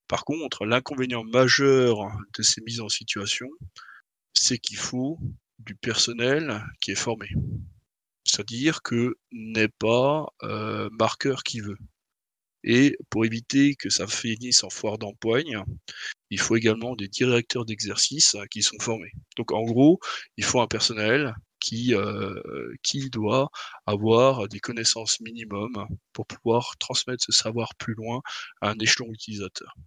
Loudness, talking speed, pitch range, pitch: -24 LUFS, 140 wpm, 110-125 Hz, 115 Hz